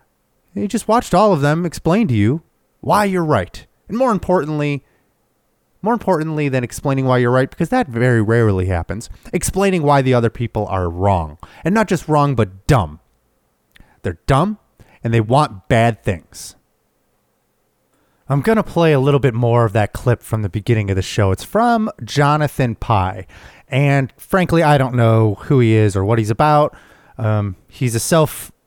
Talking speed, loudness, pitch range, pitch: 175 wpm, -17 LUFS, 110-160 Hz, 130 Hz